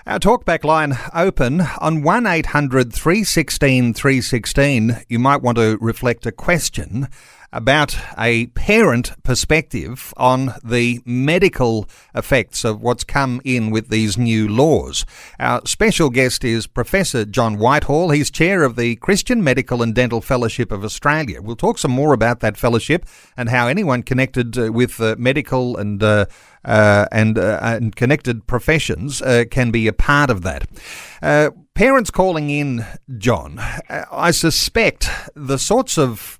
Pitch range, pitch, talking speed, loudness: 115-150 Hz, 125 Hz, 160 wpm, -17 LUFS